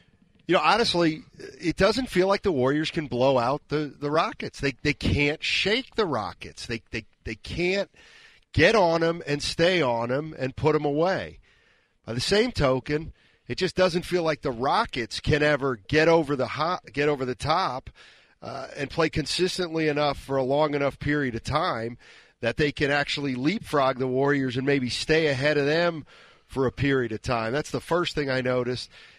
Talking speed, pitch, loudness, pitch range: 190 wpm, 145 Hz, -25 LUFS, 130-165 Hz